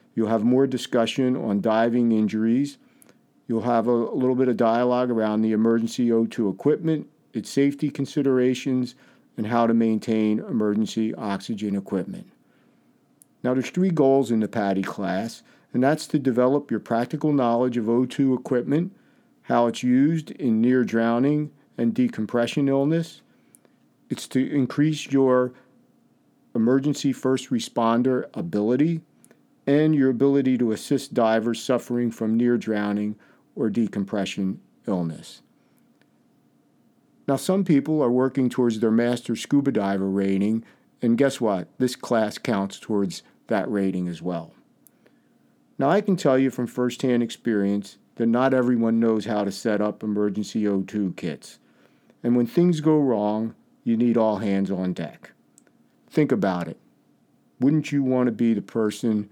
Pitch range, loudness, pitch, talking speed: 110-135 Hz, -23 LUFS, 120 Hz, 140 wpm